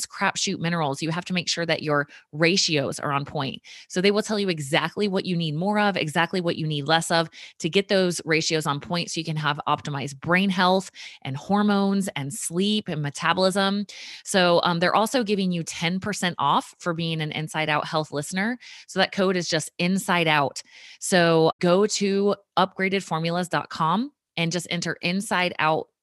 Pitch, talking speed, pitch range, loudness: 175 Hz, 185 wpm, 160-195 Hz, -24 LUFS